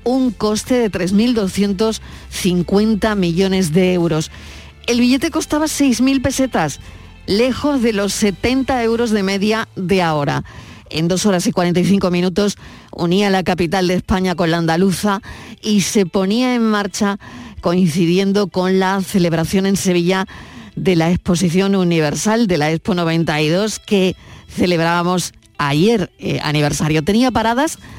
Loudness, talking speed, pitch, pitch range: -16 LUFS, 130 wpm, 195 Hz, 175-220 Hz